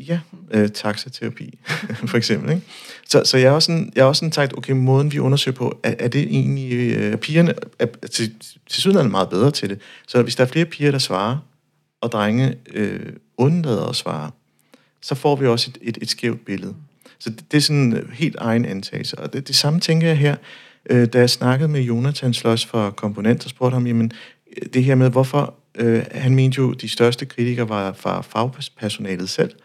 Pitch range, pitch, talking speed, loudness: 115-145 Hz, 125 Hz, 210 wpm, -19 LUFS